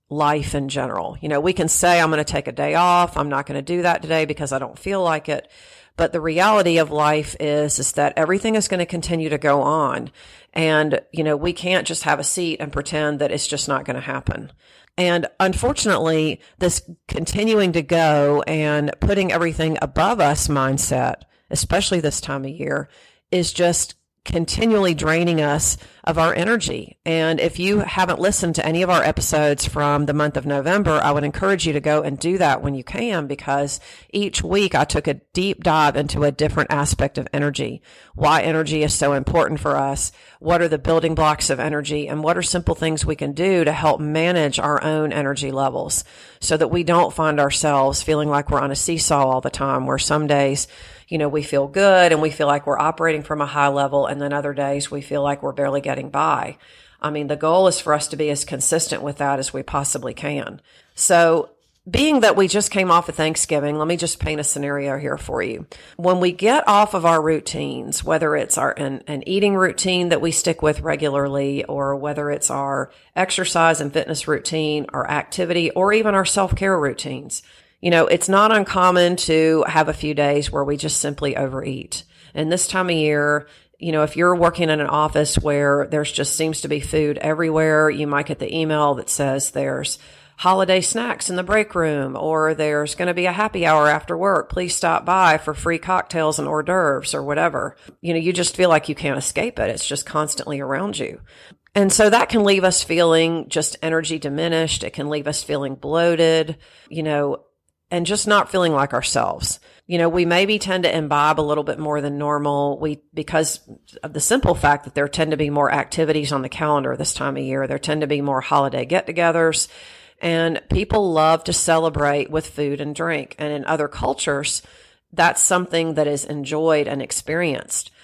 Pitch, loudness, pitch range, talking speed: 155 Hz, -19 LUFS, 145-175 Hz, 205 wpm